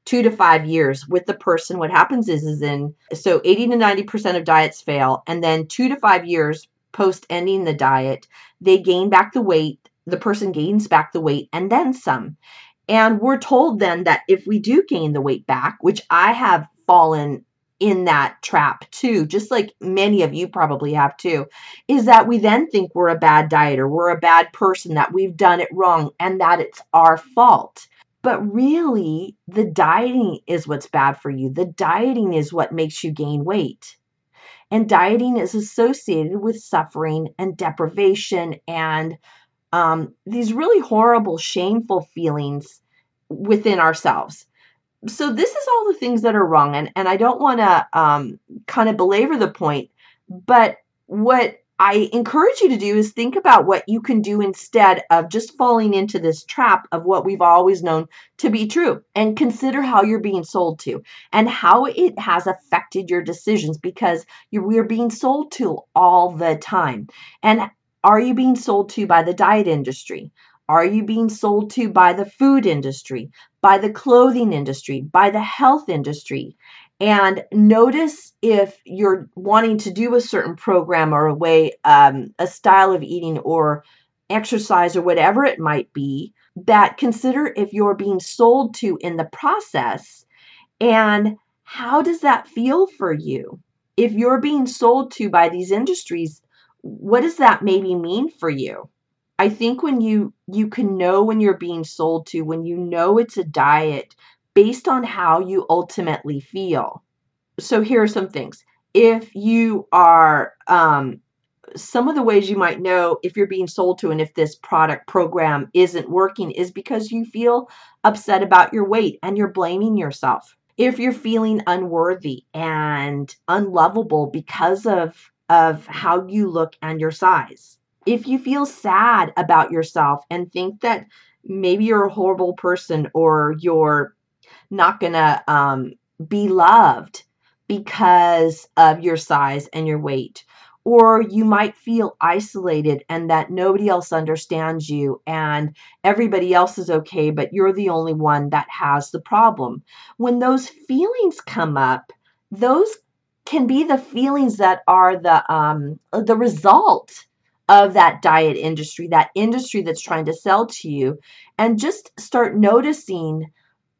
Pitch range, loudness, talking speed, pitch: 160-225 Hz, -17 LUFS, 165 wpm, 190 Hz